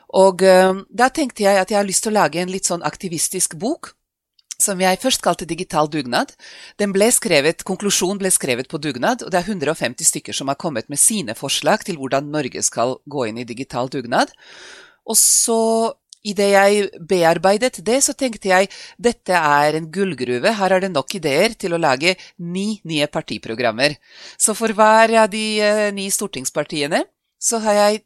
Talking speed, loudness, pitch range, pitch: 180 wpm, -18 LUFS, 160-215 Hz, 190 Hz